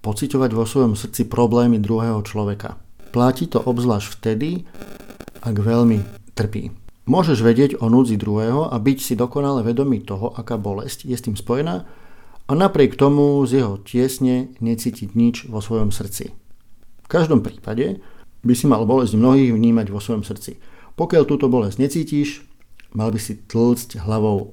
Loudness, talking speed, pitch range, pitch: -19 LUFS, 155 wpm, 110-130 Hz, 120 Hz